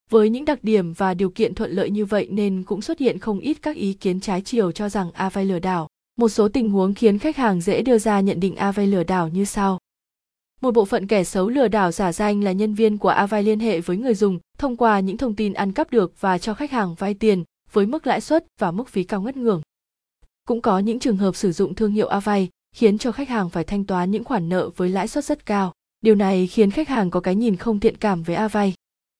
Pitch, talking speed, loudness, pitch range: 205 Hz, 255 wpm, -21 LUFS, 190-225 Hz